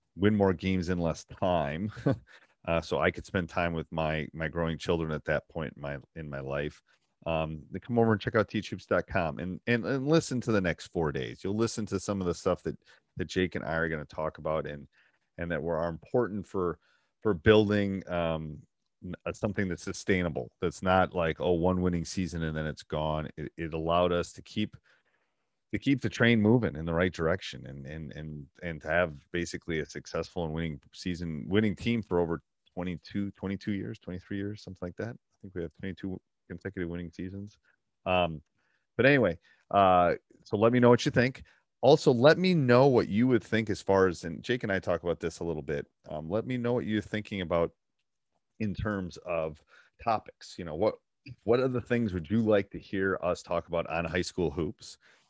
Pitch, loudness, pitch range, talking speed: 90 Hz, -30 LUFS, 80-105 Hz, 205 wpm